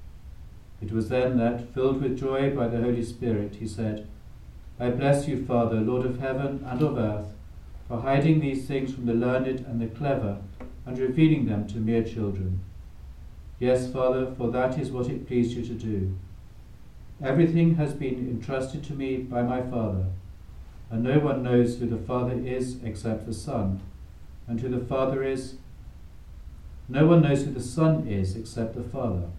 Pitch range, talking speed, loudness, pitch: 105-130 Hz, 175 wpm, -27 LUFS, 120 Hz